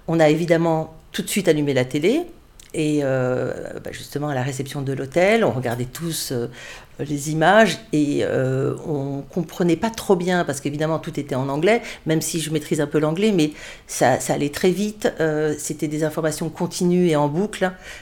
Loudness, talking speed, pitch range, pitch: -21 LUFS, 175 wpm, 145-180 Hz, 155 Hz